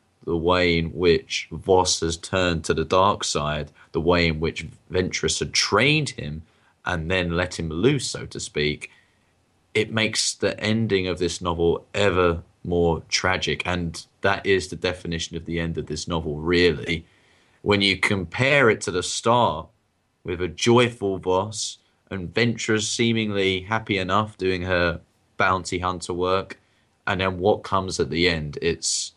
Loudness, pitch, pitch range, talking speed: -23 LUFS, 90 Hz, 85-100 Hz, 160 wpm